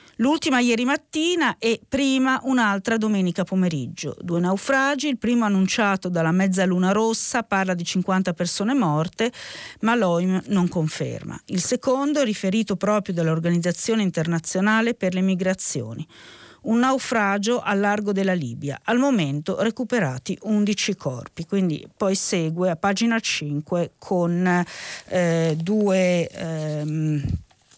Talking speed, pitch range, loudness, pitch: 120 wpm, 170-225 Hz, -22 LUFS, 190 Hz